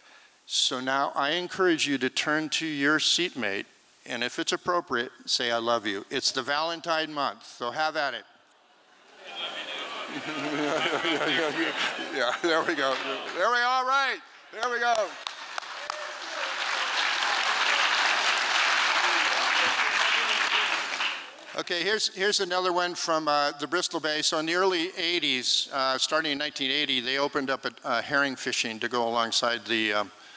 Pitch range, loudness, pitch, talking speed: 130-175 Hz, -26 LUFS, 150 Hz, 135 wpm